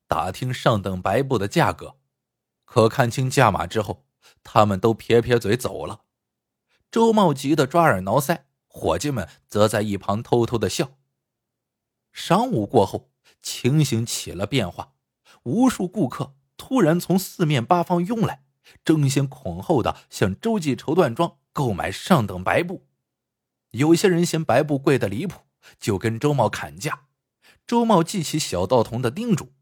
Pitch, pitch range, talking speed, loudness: 135 Hz, 115-165 Hz, 220 characters per minute, -22 LUFS